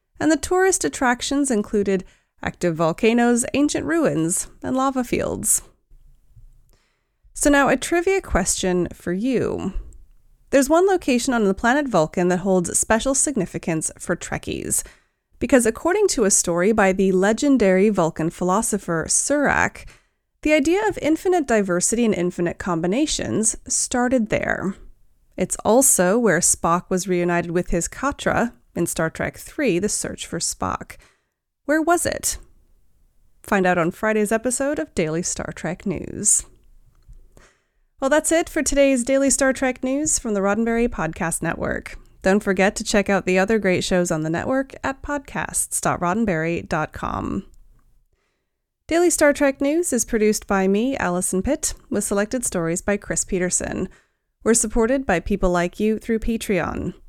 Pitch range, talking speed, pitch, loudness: 180-270 Hz, 140 wpm, 220 Hz, -20 LUFS